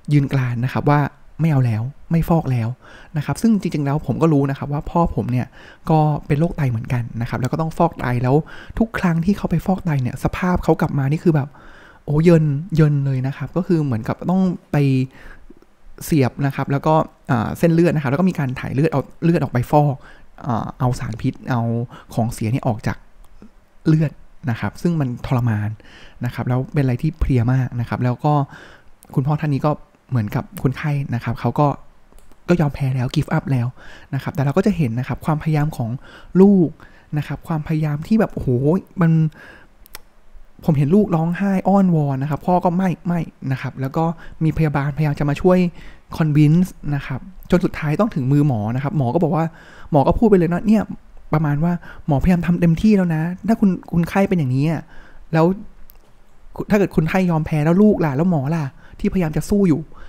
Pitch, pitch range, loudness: 150 Hz, 135-170 Hz, -19 LUFS